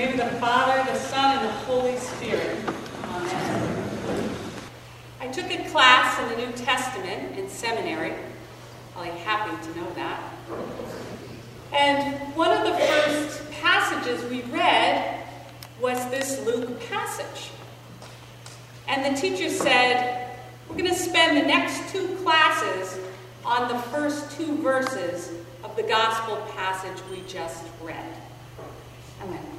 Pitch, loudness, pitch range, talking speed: 260 Hz, -24 LUFS, 240-315 Hz, 125 wpm